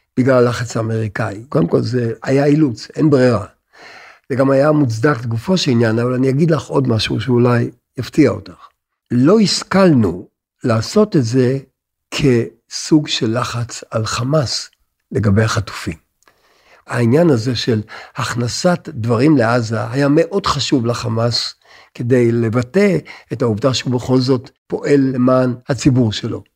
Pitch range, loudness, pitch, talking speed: 115-145 Hz, -16 LUFS, 125 Hz, 135 wpm